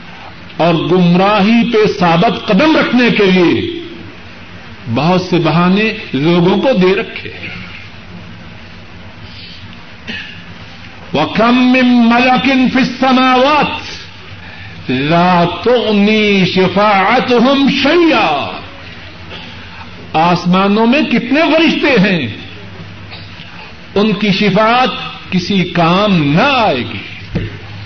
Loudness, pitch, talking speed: -11 LUFS, 175 Hz, 80 wpm